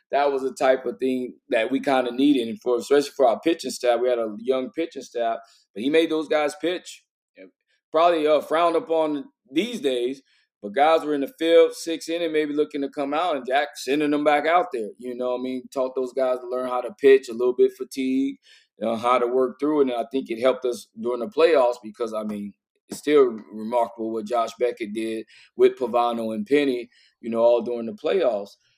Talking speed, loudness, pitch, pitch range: 225 wpm, -23 LUFS, 130 Hz, 120-155 Hz